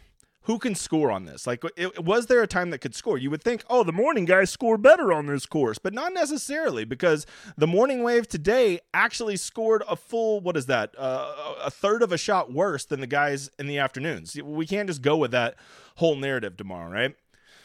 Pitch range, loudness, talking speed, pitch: 145-230 Hz, -25 LUFS, 220 wpm, 180 Hz